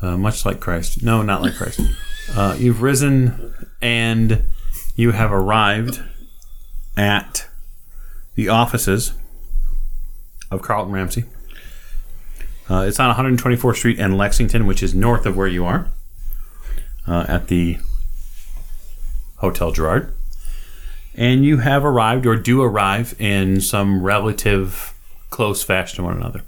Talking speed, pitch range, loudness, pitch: 125 wpm, 85-115 Hz, -18 LUFS, 100 Hz